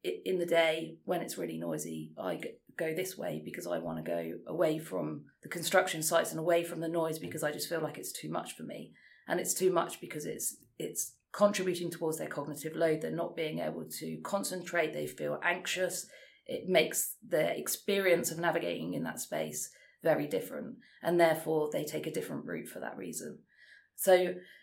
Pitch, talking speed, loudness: 165 Hz, 190 wpm, -33 LUFS